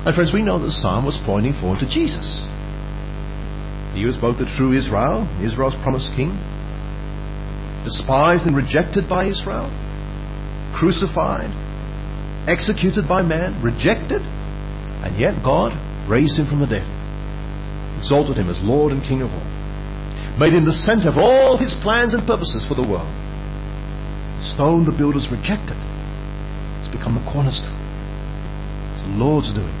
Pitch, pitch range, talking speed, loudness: 145 Hz, 120-170 Hz, 145 wpm, -20 LUFS